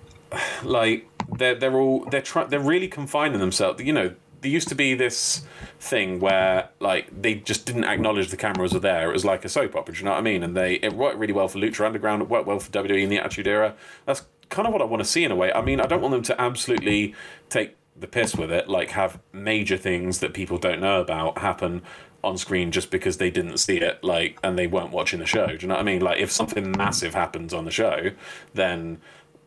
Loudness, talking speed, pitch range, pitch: -24 LUFS, 250 wpm, 95-125 Hz, 105 Hz